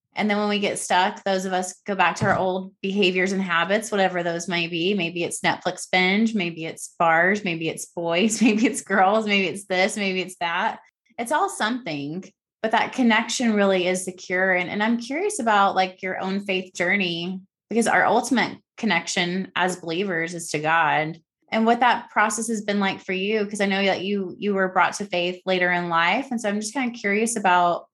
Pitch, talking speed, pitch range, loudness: 190 Hz, 215 wpm, 180-215 Hz, -22 LUFS